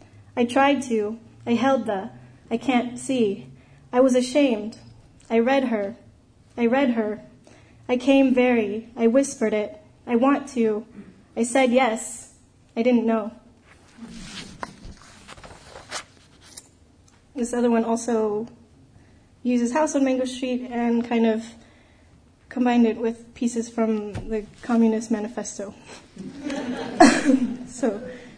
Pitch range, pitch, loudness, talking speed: 215-250 Hz, 235 Hz, -23 LUFS, 115 wpm